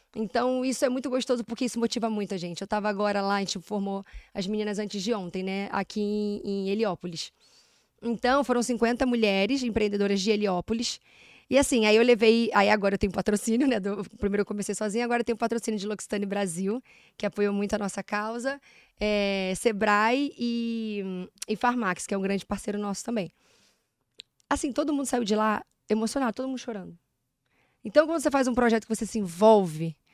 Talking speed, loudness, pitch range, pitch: 185 wpm, -27 LUFS, 200-235 Hz, 215 Hz